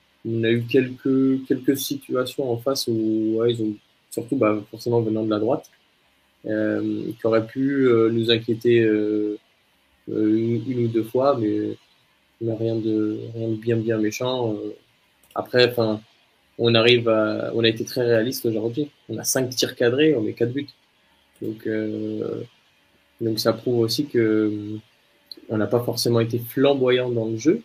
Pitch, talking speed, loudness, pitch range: 115 Hz, 170 wpm, -22 LUFS, 110-125 Hz